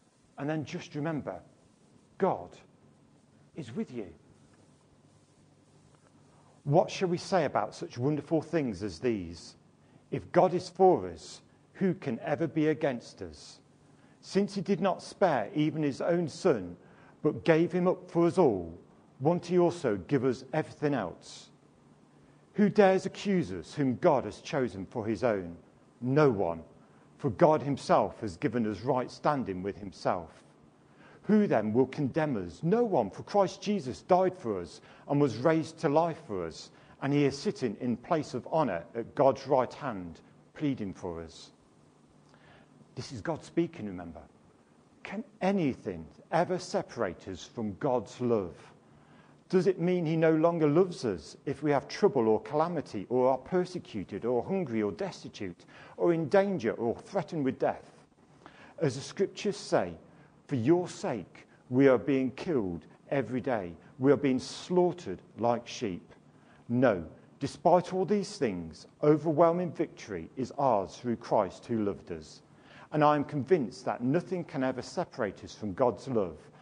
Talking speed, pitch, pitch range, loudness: 155 wpm, 150 Hz, 120-180 Hz, -30 LUFS